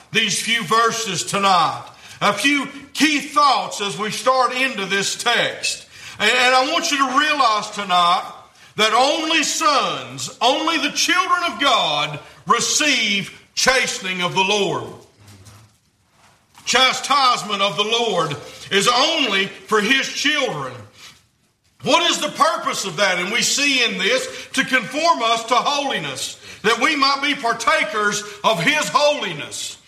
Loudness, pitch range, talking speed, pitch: -17 LUFS, 195-285 Hz, 135 wpm, 235 Hz